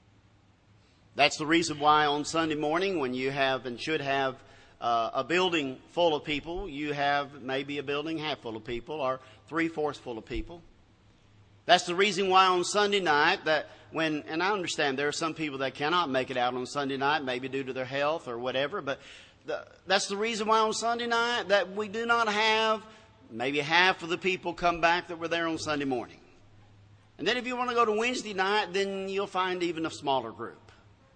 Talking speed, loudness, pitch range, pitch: 210 wpm, -28 LUFS, 130-180 Hz, 150 Hz